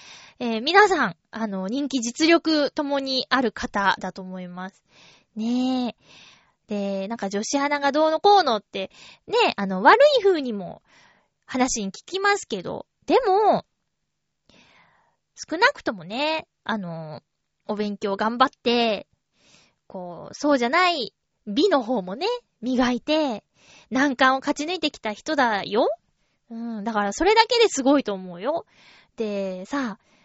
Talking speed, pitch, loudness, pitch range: 245 characters per minute, 250 Hz, -22 LUFS, 205-300 Hz